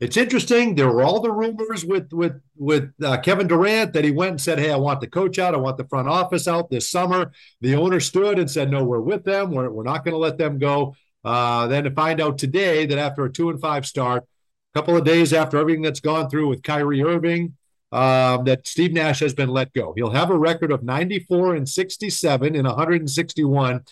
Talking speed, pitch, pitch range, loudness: 230 wpm, 155 Hz, 135-175 Hz, -20 LUFS